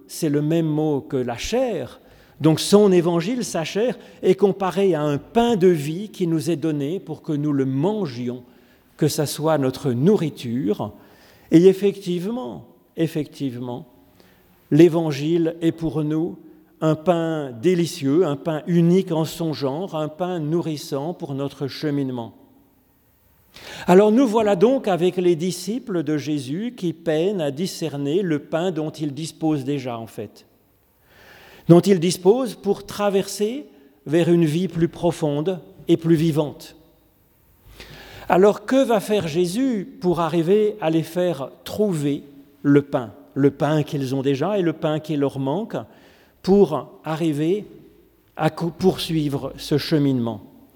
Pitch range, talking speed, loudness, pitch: 145-185 Hz, 140 wpm, -21 LUFS, 160 Hz